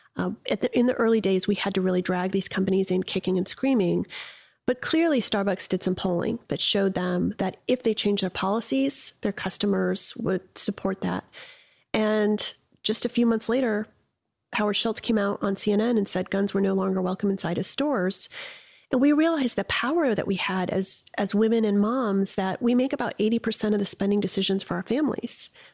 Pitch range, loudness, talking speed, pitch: 190-235 Hz, -25 LUFS, 200 wpm, 205 Hz